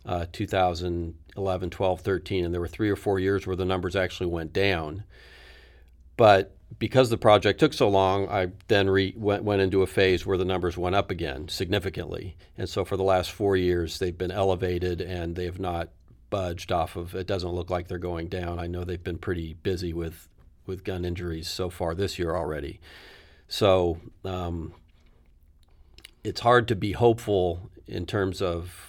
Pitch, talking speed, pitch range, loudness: 90 Hz, 185 wpm, 85-95 Hz, -26 LUFS